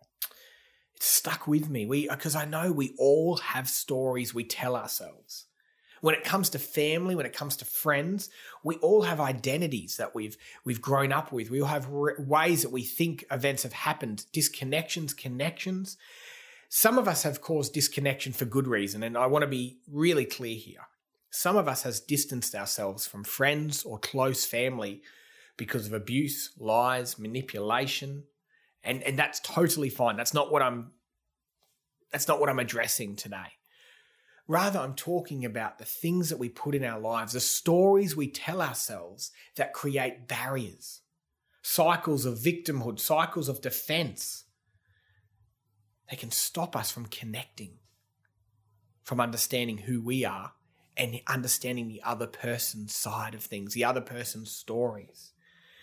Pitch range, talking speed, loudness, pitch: 115-150 Hz, 155 wpm, -29 LUFS, 130 Hz